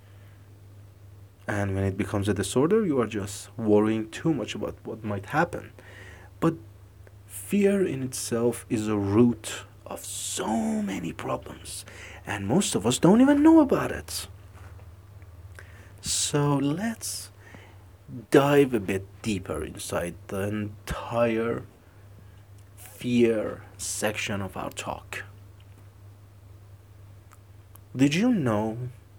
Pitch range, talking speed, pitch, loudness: 100-115 Hz, 110 wpm, 100 Hz, -26 LUFS